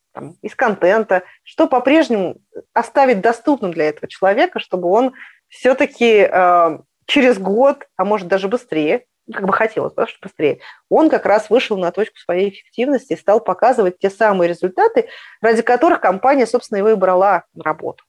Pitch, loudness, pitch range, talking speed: 220 Hz, -16 LUFS, 185-260 Hz, 155 wpm